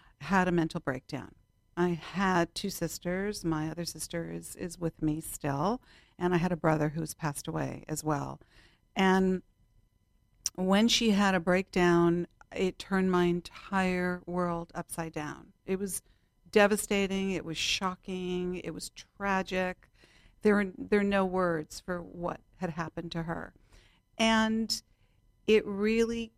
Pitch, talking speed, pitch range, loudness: 180 Hz, 140 wpm, 160-195 Hz, -31 LUFS